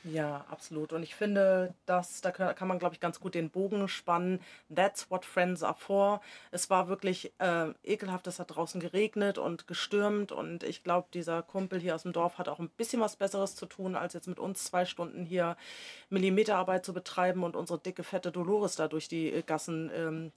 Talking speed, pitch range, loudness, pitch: 205 wpm, 170-195 Hz, -33 LUFS, 180 Hz